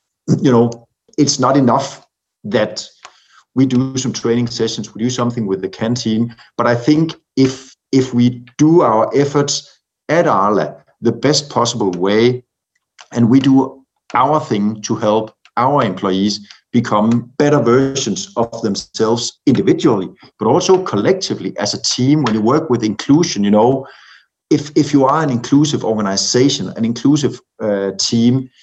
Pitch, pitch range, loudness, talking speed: 120 Hz, 110-135 Hz, -15 LUFS, 150 wpm